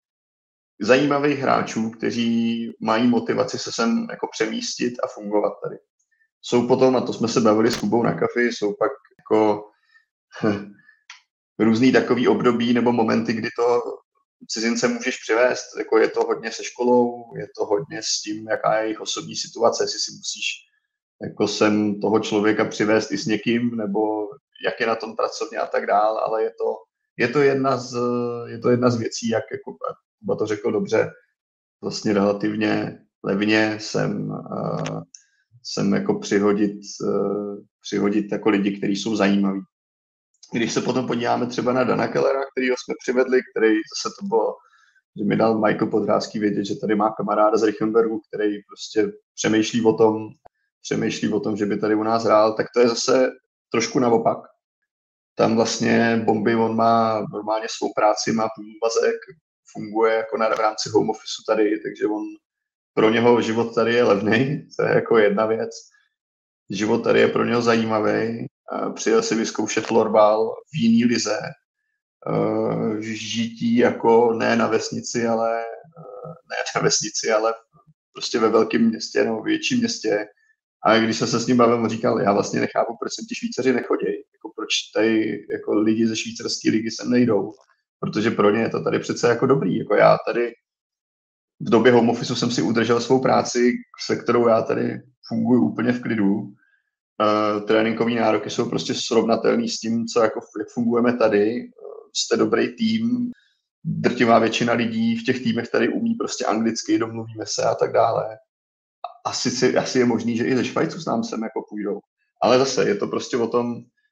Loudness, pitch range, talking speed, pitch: -21 LUFS, 110-175 Hz, 170 wpm, 115 Hz